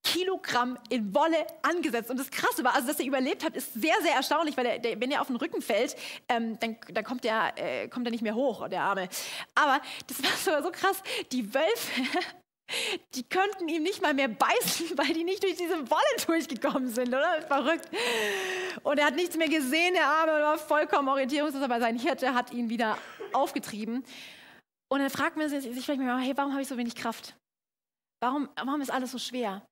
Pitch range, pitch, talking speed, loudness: 250-325 Hz, 280 Hz, 200 wpm, -29 LUFS